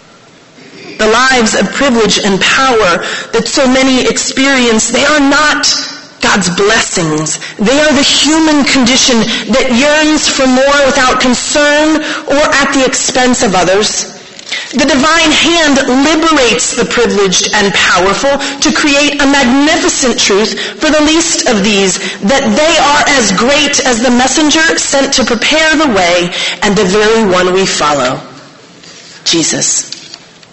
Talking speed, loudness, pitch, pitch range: 140 wpm, -8 LUFS, 260 Hz, 215-290 Hz